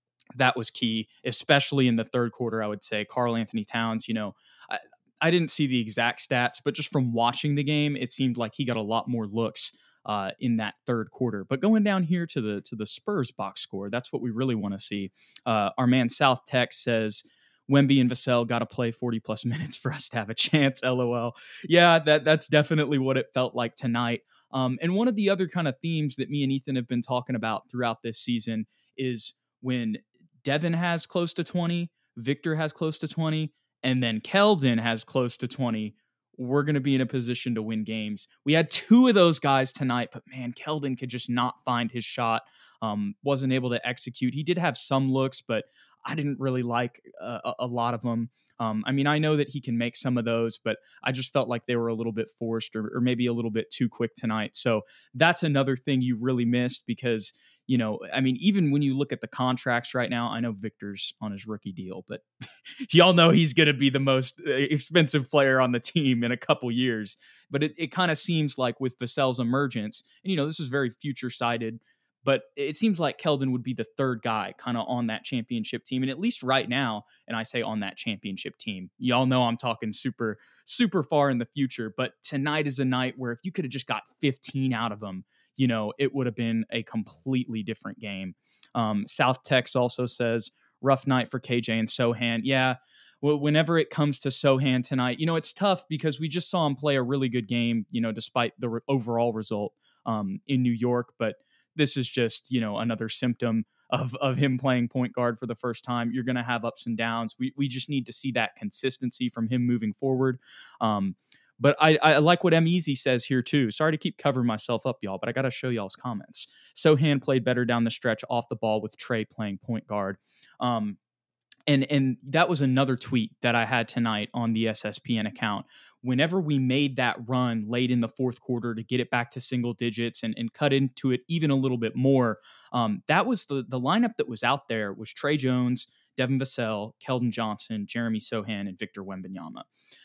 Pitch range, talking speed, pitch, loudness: 115-140 Hz, 220 wpm, 125 Hz, -27 LUFS